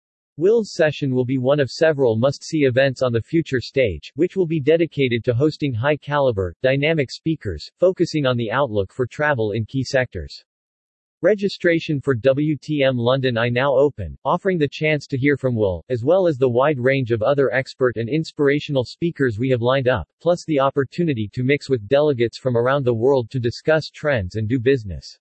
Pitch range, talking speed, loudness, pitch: 125-150 Hz, 190 wpm, -20 LUFS, 135 Hz